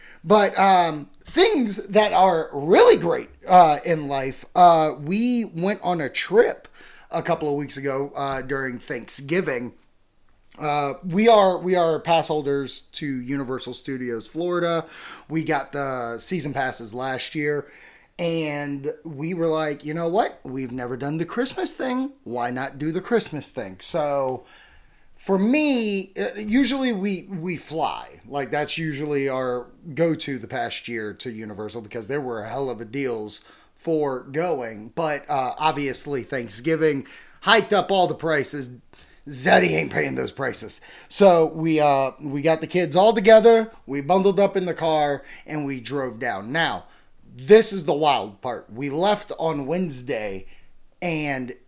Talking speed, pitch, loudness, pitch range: 155 wpm, 150 Hz, -22 LUFS, 135-180 Hz